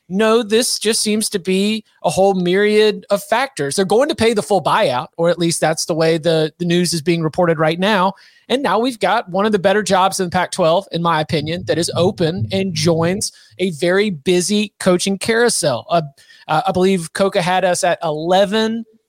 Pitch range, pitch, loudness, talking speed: 170-210 Hz, 185 Hz, -16 LUFS, 205 wpm